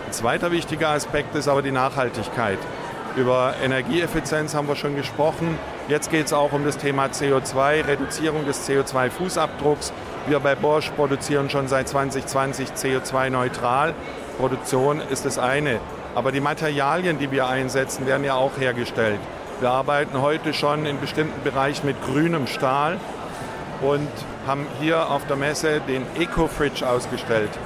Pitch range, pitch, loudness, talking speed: 130-150 Hz, 140 Hz, -23 LUFS, 145 wpm